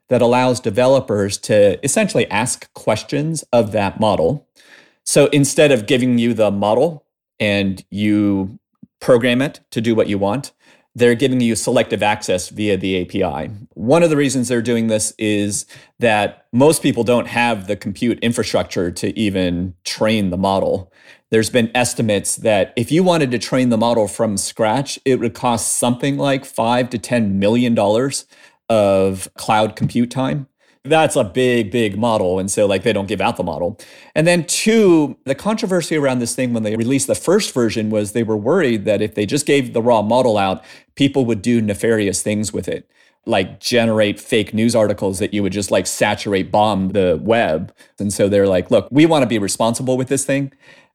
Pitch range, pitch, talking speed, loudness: 105-130 Hz, 115 Hz, 185 wpm, -17 LUFS